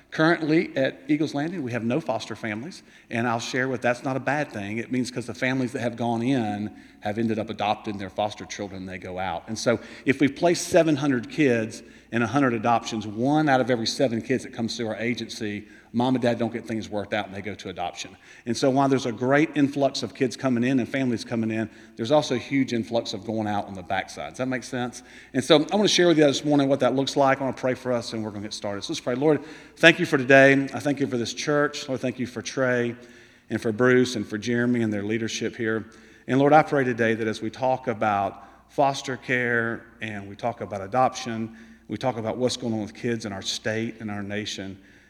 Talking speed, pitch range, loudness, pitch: 250 wpm, 110-135 Hz, -25 LUFS, 120 Hz